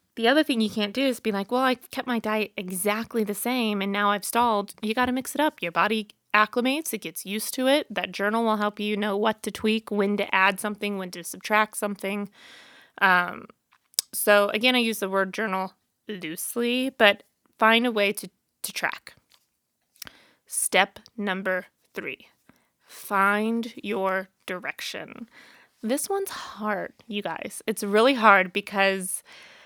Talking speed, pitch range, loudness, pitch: 170 wpm, 200-240 Hz, -25 LUFS, 215 Hz